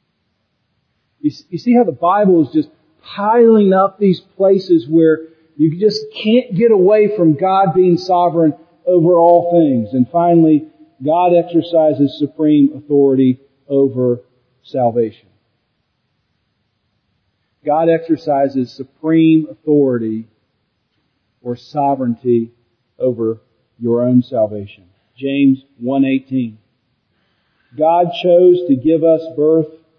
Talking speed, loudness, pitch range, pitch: 100 wpm, -14 LUFS, 125-175 Hz, 155 Hz